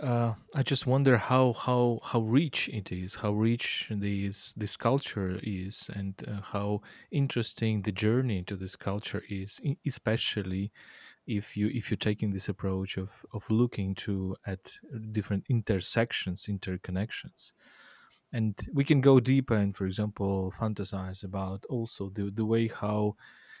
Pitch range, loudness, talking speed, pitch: 100-115 Hz, -30 LUFS, 145 wpm, 105 Hz